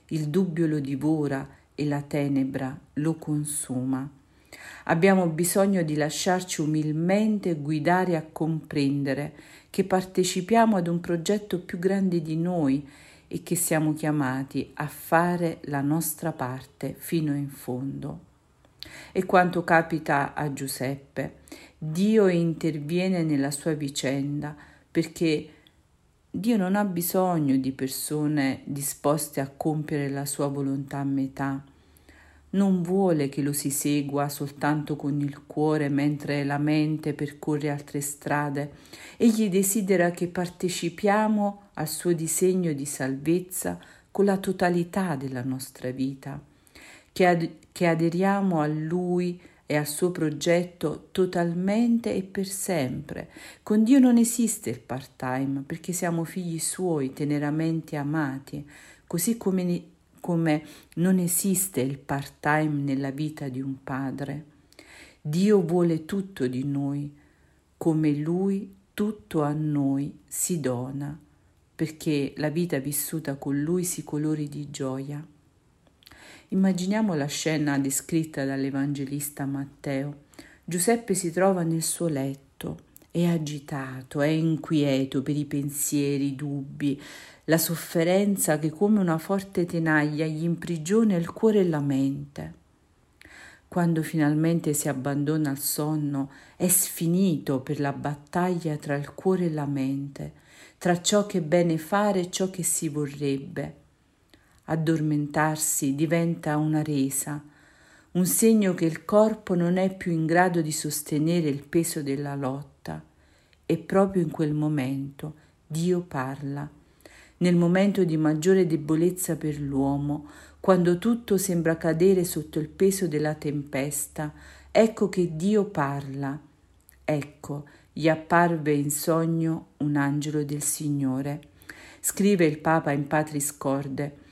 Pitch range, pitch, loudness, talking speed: 140-175 Hz, 155 Hz, -26 LUFS, 125 wpm